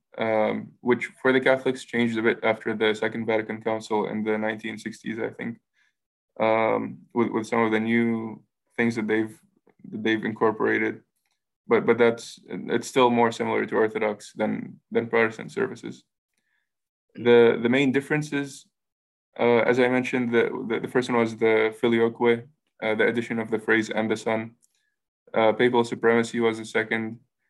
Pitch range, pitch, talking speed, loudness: 110-120 Hz, 115 Hz, 160 wpm, -24 LUFS